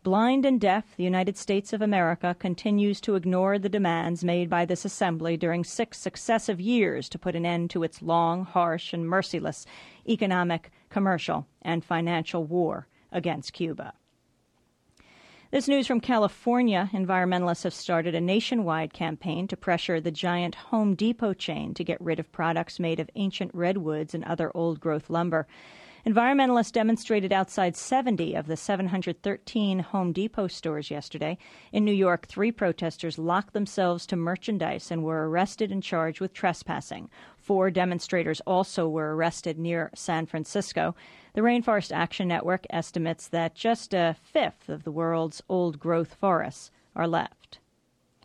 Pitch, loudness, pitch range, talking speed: 180 Hz, -27 LUFS, 165-200 Hz, 150 wpm